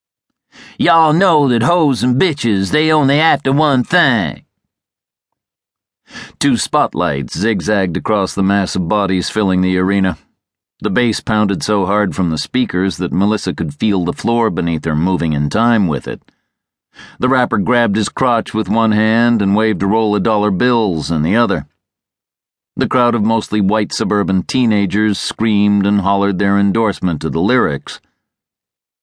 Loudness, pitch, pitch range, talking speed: -14 LUFS, 105 Hz, 95-115 Hz, 155 wpm